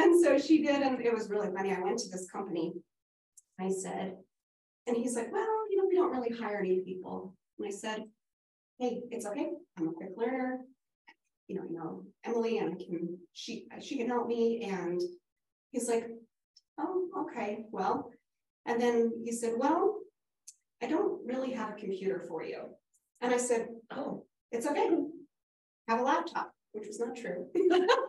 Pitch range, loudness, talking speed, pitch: 200-285 Hz, -33 LUFS, 180 wpm, 235 Hz